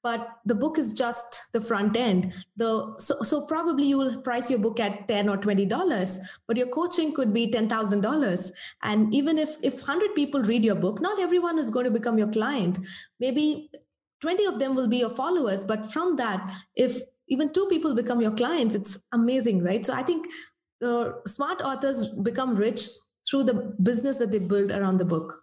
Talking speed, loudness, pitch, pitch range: 200 wpm, -25 LUFS, 240 Hz, 215-275 Hz